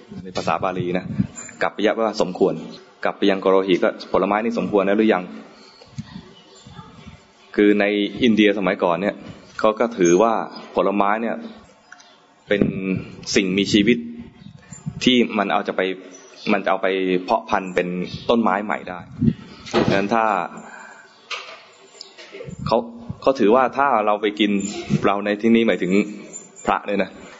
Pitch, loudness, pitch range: 100 Hz, -20 LUFS, 95-110 Hz